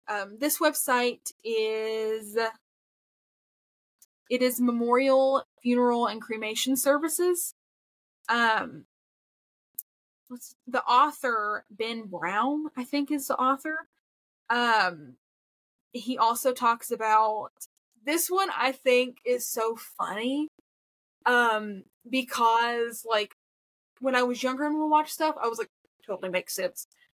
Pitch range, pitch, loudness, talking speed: 225-280 Hz, 245 Hz, -27 LUFS, 115 wpm